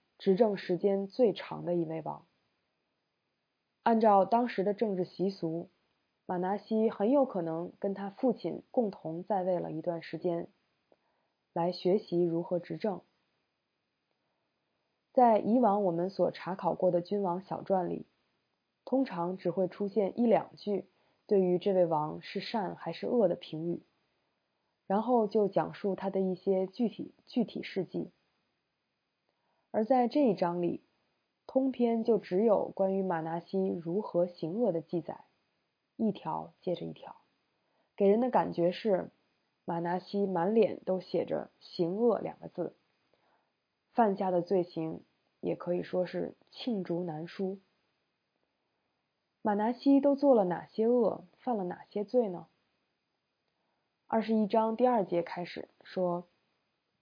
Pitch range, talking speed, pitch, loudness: 175-220 Hz, 195 characters per minute, 190 Hz, -31 LUFS